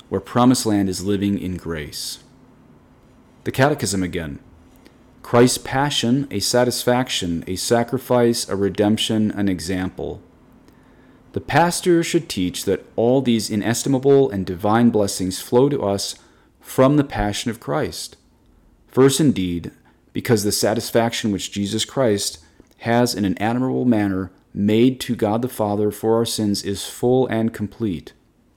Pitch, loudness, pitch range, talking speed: 110 Hz, -20 LUFS, 100-125 Hz, 135 wpm